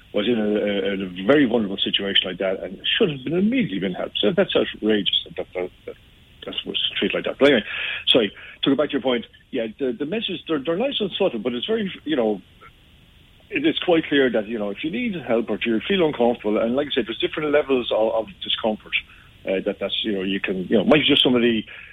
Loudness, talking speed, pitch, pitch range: -22 LUFS, 250 wpm, 120 Hz, 105-155 Hz